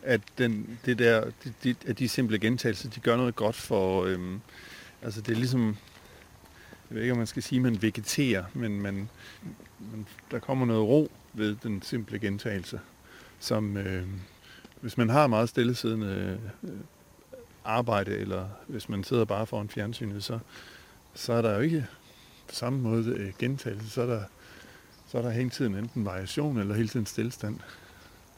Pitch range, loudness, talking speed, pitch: 100-120 Hz, -30 LUFS, 165 wpm, 110 Hz